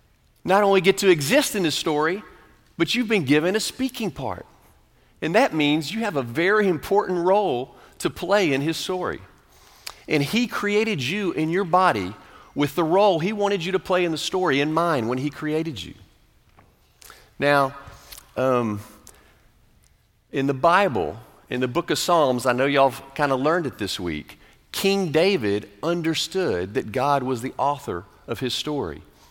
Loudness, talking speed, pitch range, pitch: -22 LUFS, 170 wpm, 135-185 Hz, 155 Hz